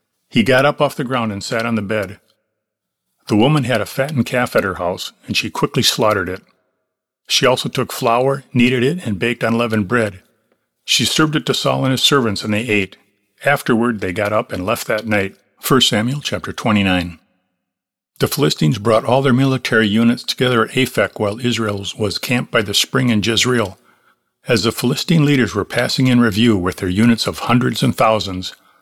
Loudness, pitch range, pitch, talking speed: -16 LUFS, 105-125 Hz, 115 Hz, 190 wpm